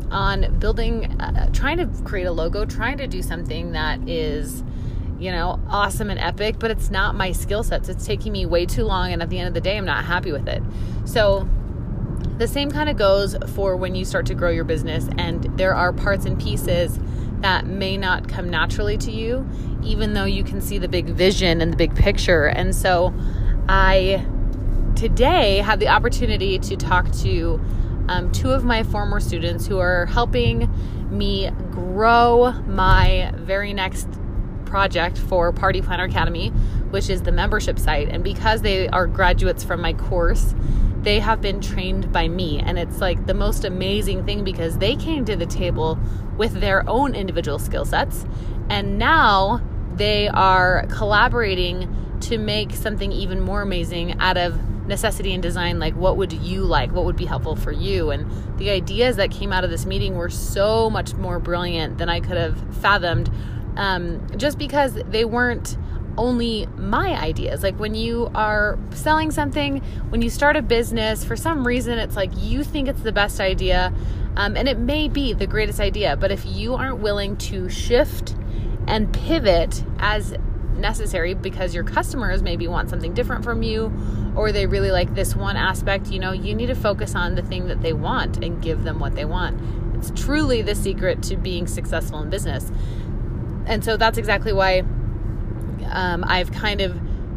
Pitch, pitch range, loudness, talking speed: 105 Hz, 95-115 Hz, -21 LUFS, 180 wpm